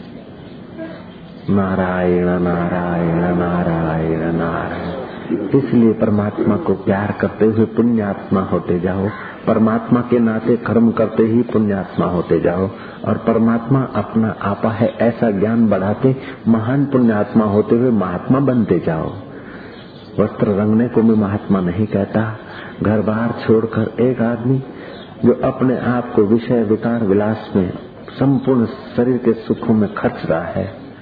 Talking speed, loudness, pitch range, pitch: 125 wpm, -17 LUFS, 100-115 Hz, 110 Hz